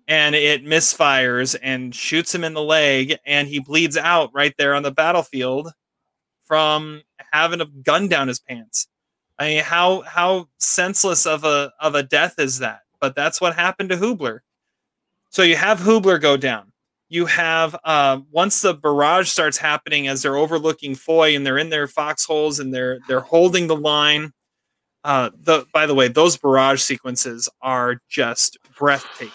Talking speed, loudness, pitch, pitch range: 170 wpm, -17 LUFS, 150 Hz, 140-165 Hz